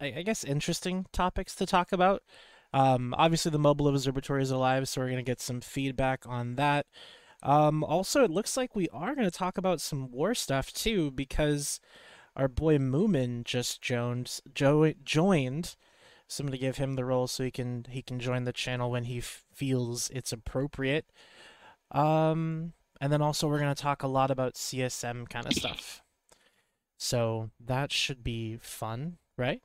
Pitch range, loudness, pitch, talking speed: 125-160 Hz, -30 LUFS, 140 Hz, 160 wpm